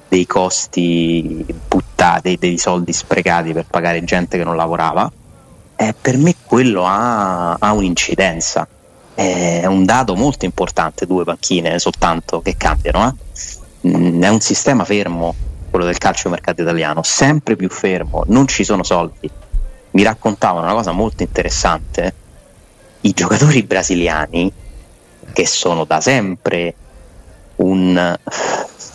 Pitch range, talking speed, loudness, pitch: 85-100 Hz, 130 wpm, -15 LUFS, 90 Hz